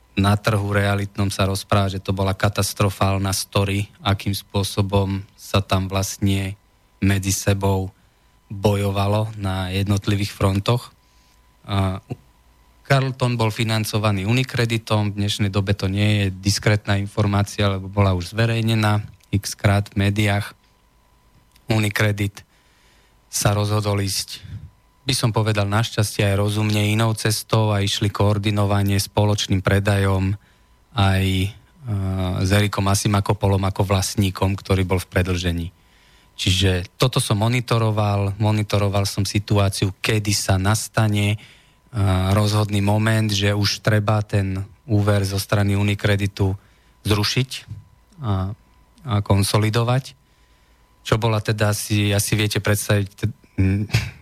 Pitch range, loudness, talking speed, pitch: 100-110 Hz, -21 LUFS, 110 wpm, 100 Hz